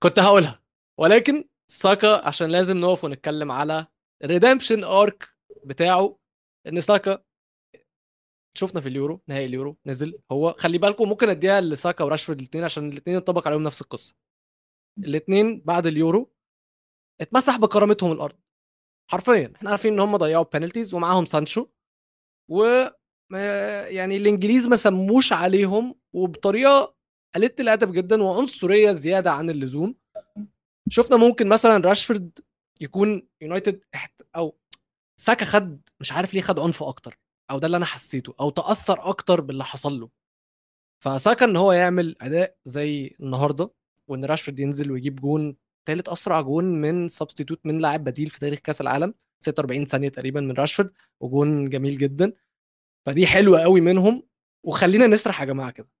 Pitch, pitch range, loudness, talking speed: 175 Hz, 145-205 Hz, -21 LUFS, 140 wpm